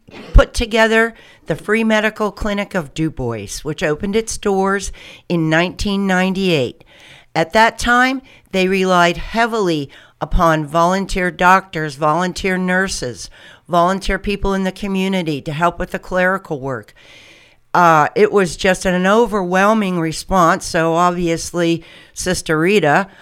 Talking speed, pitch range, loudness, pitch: 130 wpm, 165-200 Hz, -16 LUFS, 185 Hz